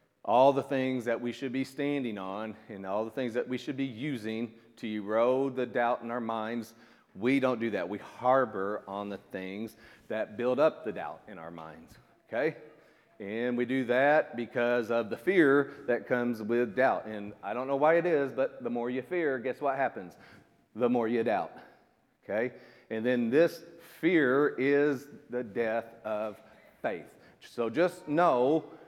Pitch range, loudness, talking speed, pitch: 115-135 Hz, -30 LUFS, 180 wpm, 120 Hz